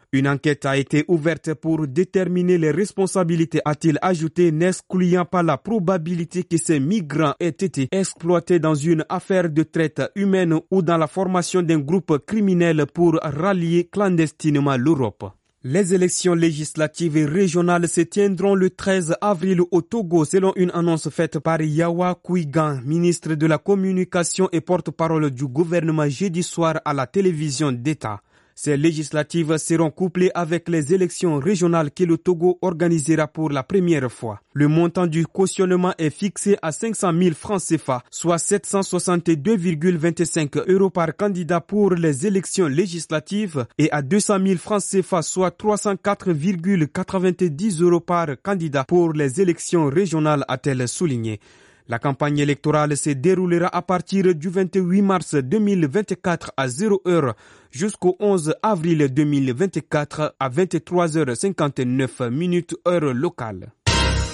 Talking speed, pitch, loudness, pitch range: 135 wpm, 170 Hz, -20 LUFS, 155-185 Hz